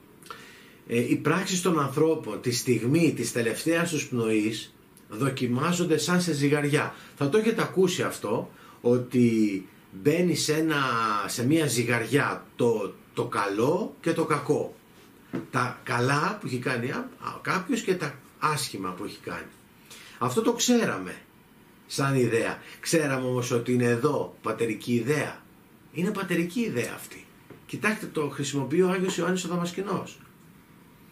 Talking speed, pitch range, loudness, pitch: 135 wpm, 120-170 Hz, -27 LUFS, 150 Hz